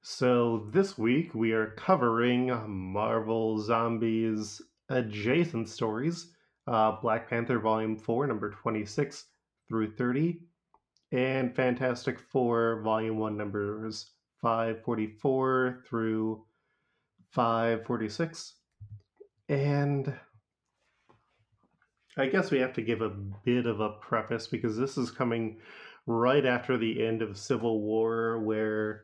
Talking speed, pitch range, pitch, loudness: 105 wpm, 110-130 Hz, 115 Hz, -30 LUFS